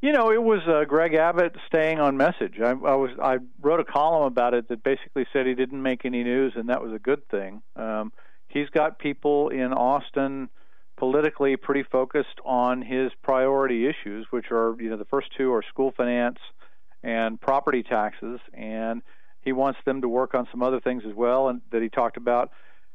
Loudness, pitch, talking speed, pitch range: -25 LUFS, 130 Hz, 200 wpm, 120-140 Hz